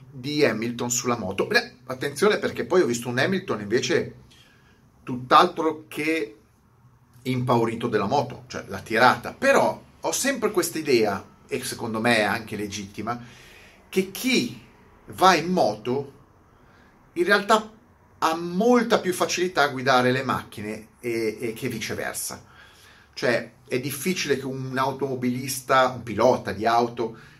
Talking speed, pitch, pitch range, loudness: 135 wpm, 130 Hz, 115-160 Hz, -24 LUFS